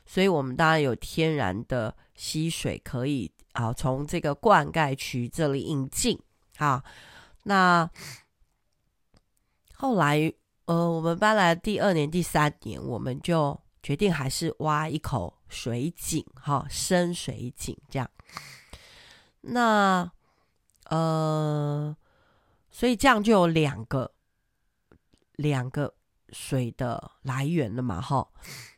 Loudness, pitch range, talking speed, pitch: -26 LUFS, 130-170 Hz, 160 characters per minute, 150 Hz